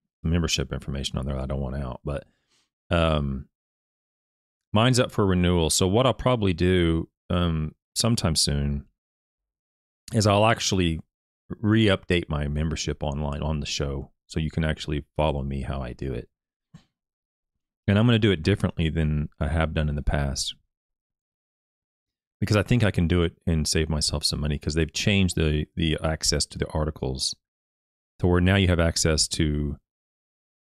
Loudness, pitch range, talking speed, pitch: -25 LUFS, 70-90 Hz, 170 wpm, 80 Hz